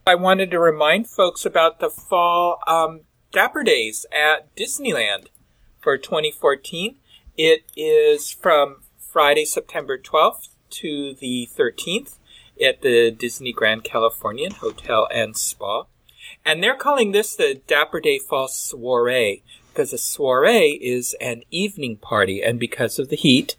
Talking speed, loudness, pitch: 135 wpm, -20 LUFS, 190 Hz